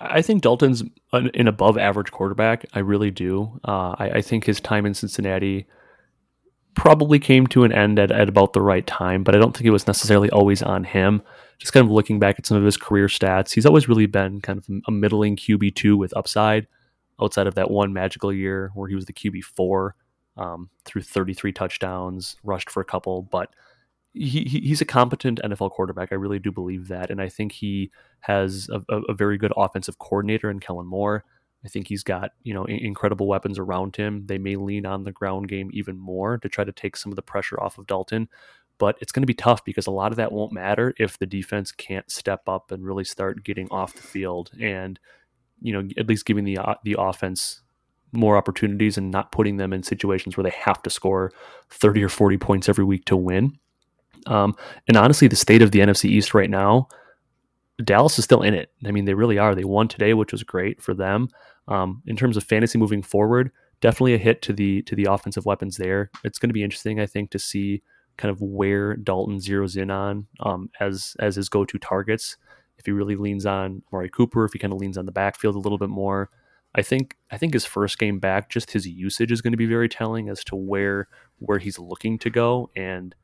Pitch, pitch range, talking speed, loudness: 100 Hz, 95-110 Hz, 220 wpm, -21 LUFS